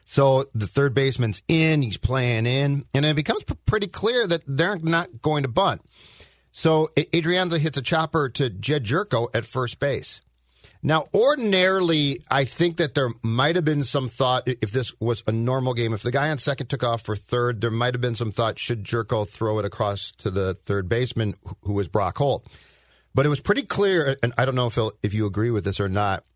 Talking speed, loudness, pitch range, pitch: 210 wpm, -23 LUFS, 110-155 Hz, 130 Hz